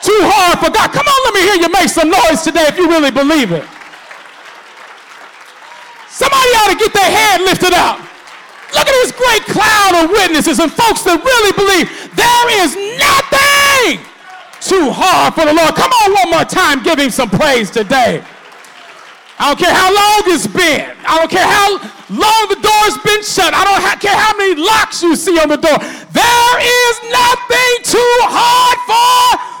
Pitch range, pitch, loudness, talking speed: 325-440 Hz, 390 Hz, -9 LUFS, 180 wpm